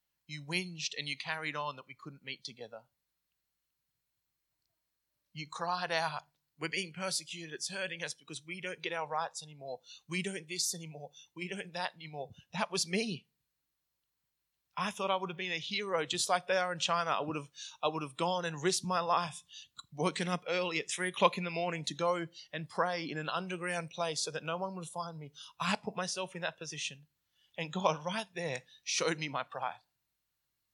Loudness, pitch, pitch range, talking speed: -35 LUFS, 170 Hz, 155-180 Hz, 195 wpm